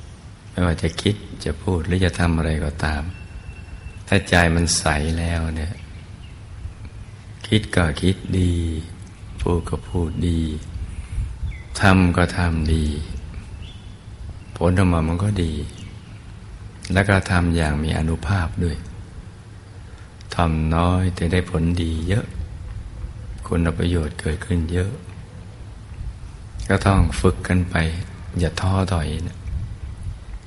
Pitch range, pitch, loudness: 85-100 Hz, 90 Hz, -22 LUFS